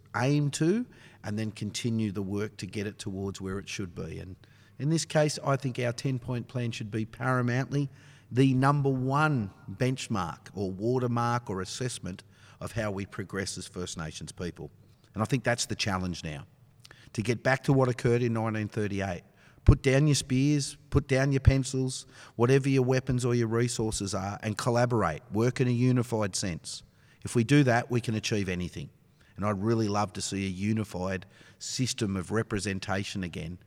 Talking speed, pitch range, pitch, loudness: 180 wpm, 100-130 Hz, 115 Hz, -29 LUFS